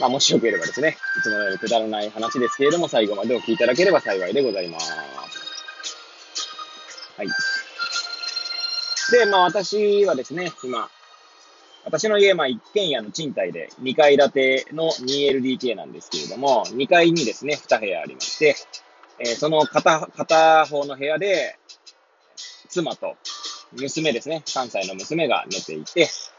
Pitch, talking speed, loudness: 170 Hz, 275 characters per minute, -21 LUFS